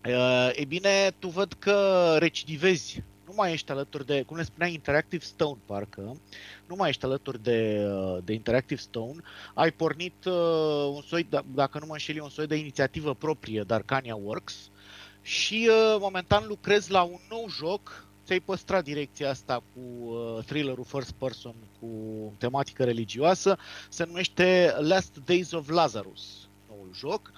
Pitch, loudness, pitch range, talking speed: 145 Hz, -27 LUFS, 115-175 Hz, 145 wpm